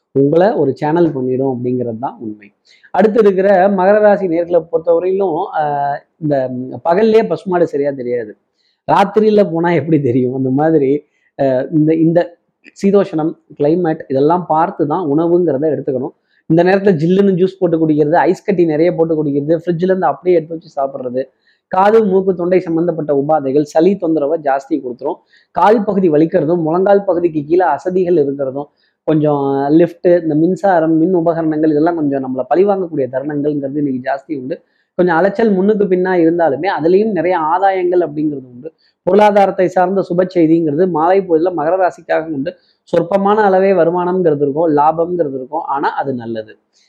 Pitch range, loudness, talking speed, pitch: 145-185 Hz, -14 LUFS, 135 wpm, 165 Hz